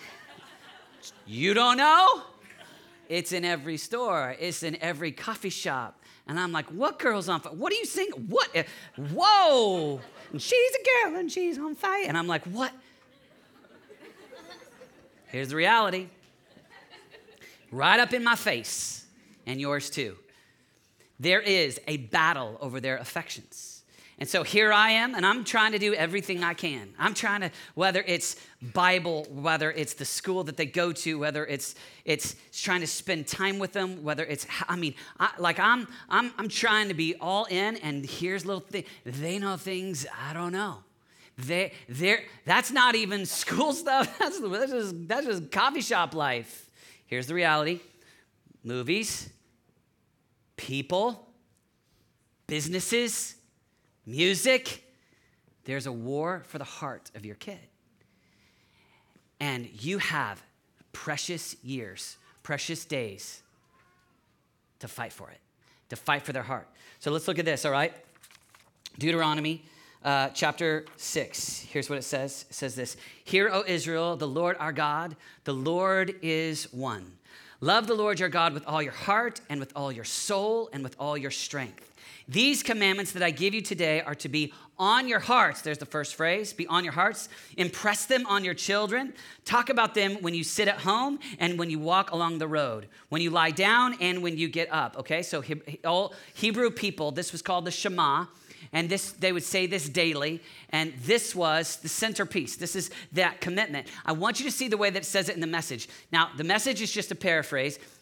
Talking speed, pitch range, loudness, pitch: 170 wpm, 150-200 Hz, -27 LUFS, 170 Hz